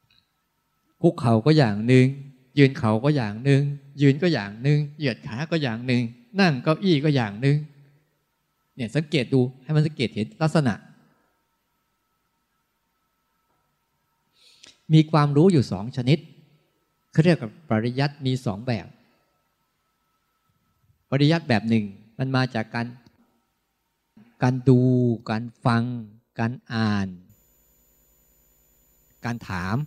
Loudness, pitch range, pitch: -23 LUFS, 110-150 Hz, 130 Hz